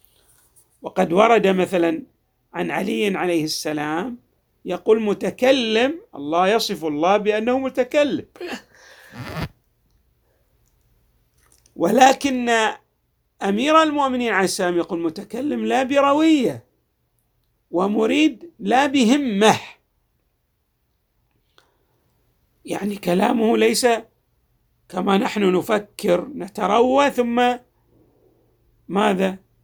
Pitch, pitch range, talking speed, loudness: 225 Hz, 190-255 Hz, 70 wpm, -19 LUFS